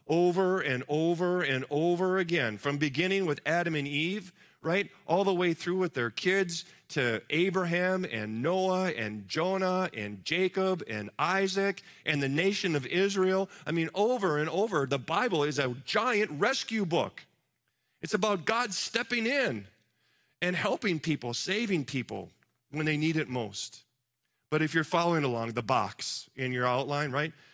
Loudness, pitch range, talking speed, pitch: -30 LUFS, 135-185 Hz, 160 wpm, 165 Hz